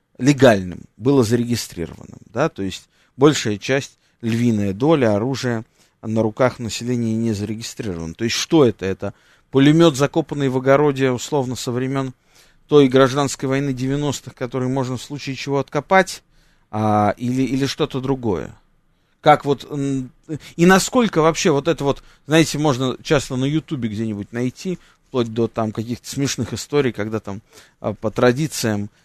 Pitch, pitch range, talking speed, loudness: 130 Hz, 115-145 Hz, 140 wpm, -19 LUFS